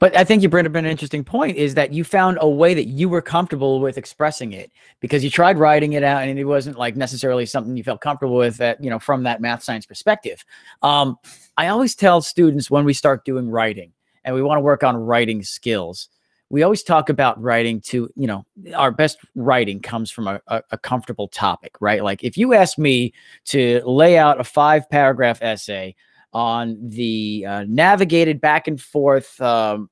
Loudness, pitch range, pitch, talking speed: -18 LUFS, 120-155 Hz, 135 Hz, 205 wpm